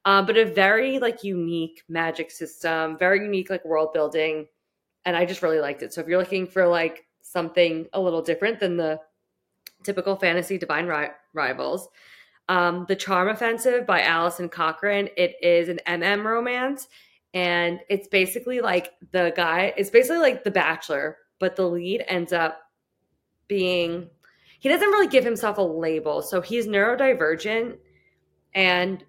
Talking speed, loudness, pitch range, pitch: 155 wpm, -23 LUFS, 165-200 Hz, 180 Hz